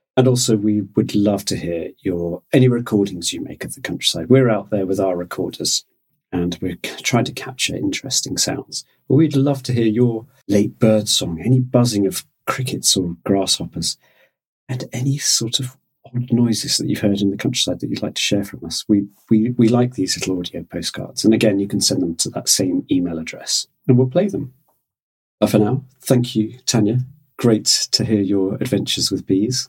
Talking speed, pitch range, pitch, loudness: 200 wpm, 100-130 Hz, 110 Hz, -18 LUFS